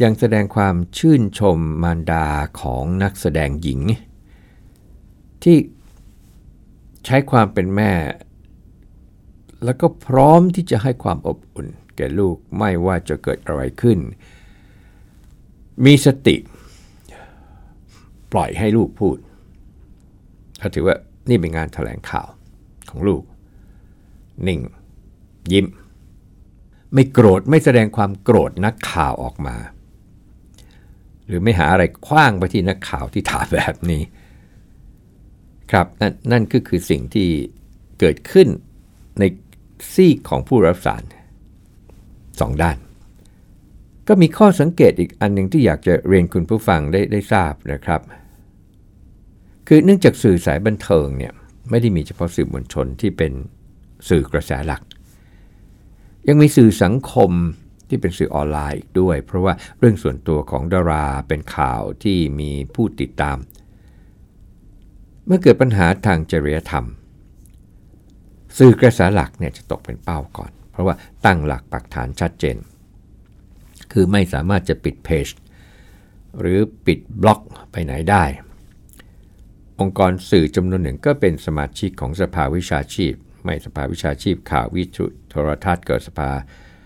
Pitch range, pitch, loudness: 85-105 Hz, 95 Hz, -17 LUFS